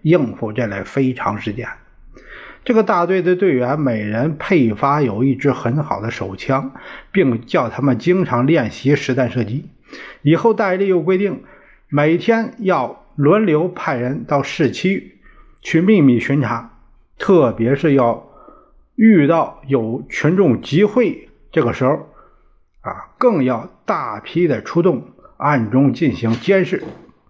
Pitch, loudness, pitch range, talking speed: 145 Hz, -17 LUFS, 125-190 Hz, 200 characters per minute